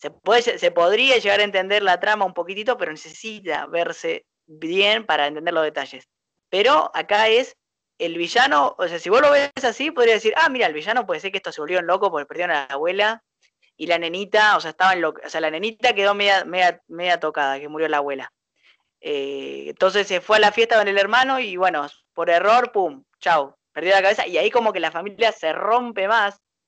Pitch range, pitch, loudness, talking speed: 165-220 Hz, 195 Hz, -19 LUFS, 220 wpm